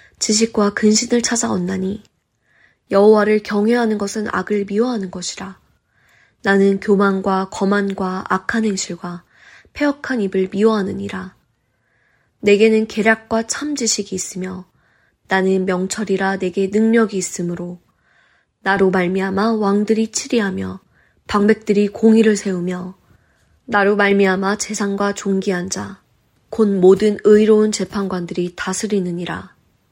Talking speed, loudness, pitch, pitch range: 270 characters per minute, -17 LUFS, 200 Hz, 185-215 Hz